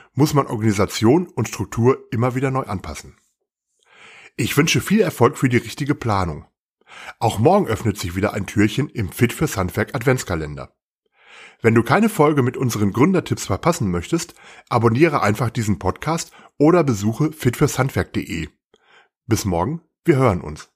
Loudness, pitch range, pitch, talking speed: -19 LUFS, 100-140 Hz, 120 Hz, 135 wpm